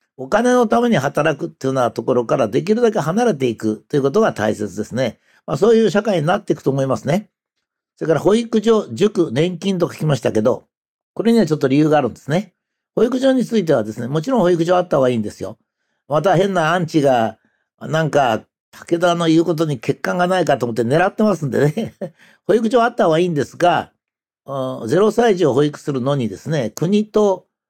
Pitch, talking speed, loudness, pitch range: 165 Hz, 420 characters per minute, -17 LUFS, 140-210 Hz